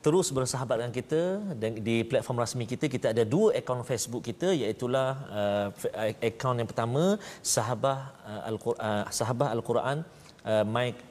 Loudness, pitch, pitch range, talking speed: -29 LUFS, 120 Hz, 115-135 Hz, 150 wpm